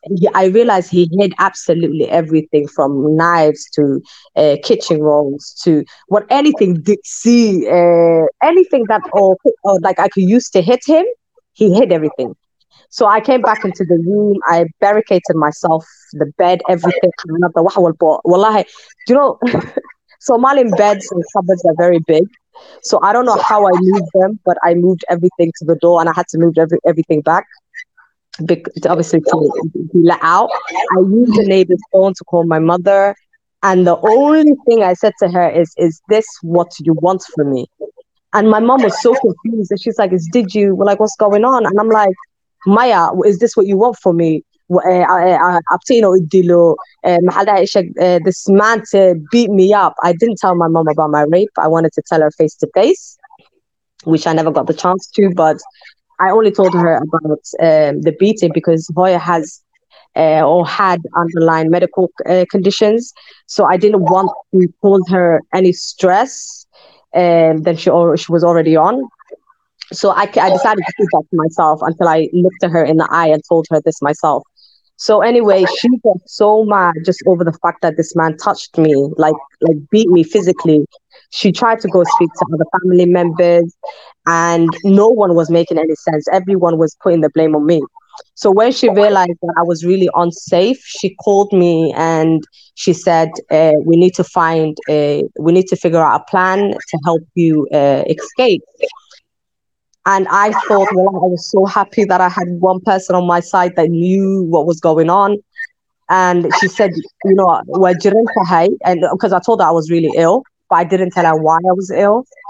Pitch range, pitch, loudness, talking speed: 165-205 Hz, 180 Hz, -12 LUFS, 185 wpm